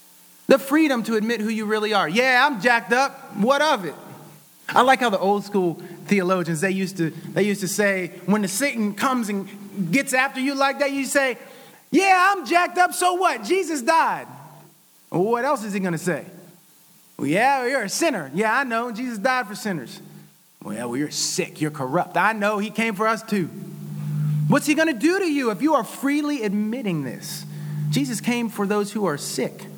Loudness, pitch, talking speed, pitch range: -22 LUFS, 220 Hz, 210 wpm, 185-275 Hz